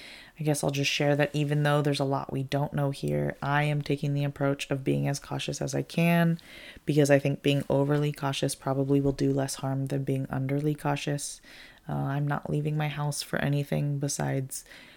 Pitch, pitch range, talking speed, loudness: 140 Hz, 135-145 Hz, 205 wpm, -28 LUFS